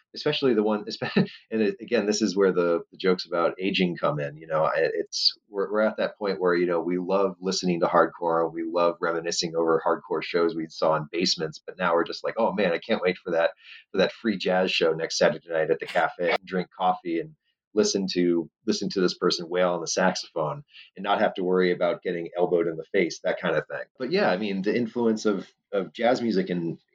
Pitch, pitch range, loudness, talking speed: 90 Hz, 85-105 Hz, -25 LUFS, 225 wpm